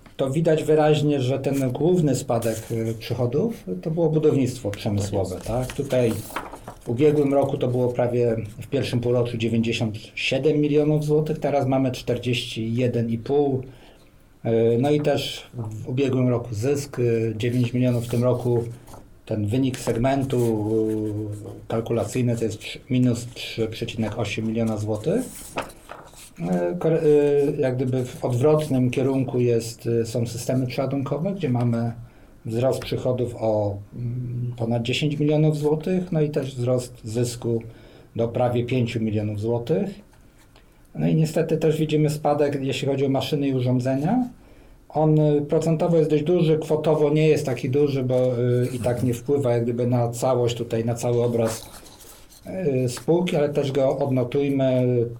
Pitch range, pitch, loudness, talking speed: 115-145 Hz, 125 Hz, -23 LUFS, 130 wpm